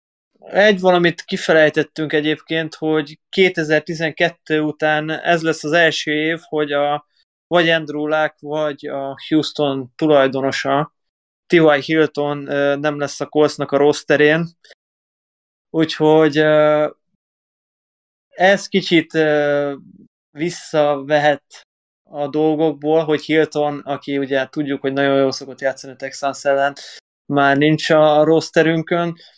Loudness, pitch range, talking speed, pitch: -17 LUFS, 145-160 Hz, 110 wpm, 150 Hz